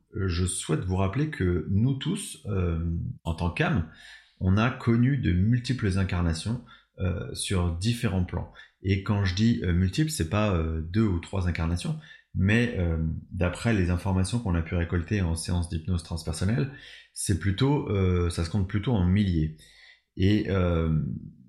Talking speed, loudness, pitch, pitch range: 160 wpm, -27 LUFS, 95 Hz, 85-110 Hz